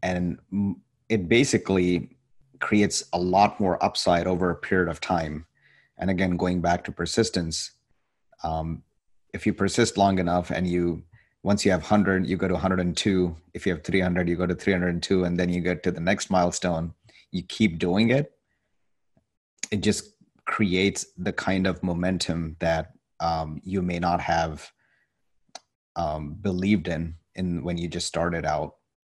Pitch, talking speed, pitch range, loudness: 90 Hz, 170 wpm, 85-95 Hz, -25 LUFS